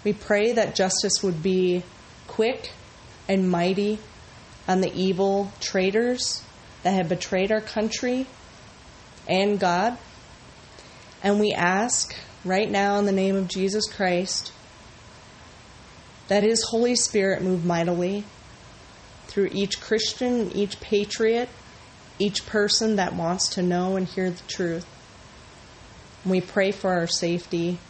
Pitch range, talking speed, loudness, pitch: 180-210 Hz, 125 wpm, -24 LUFS, 195 Hz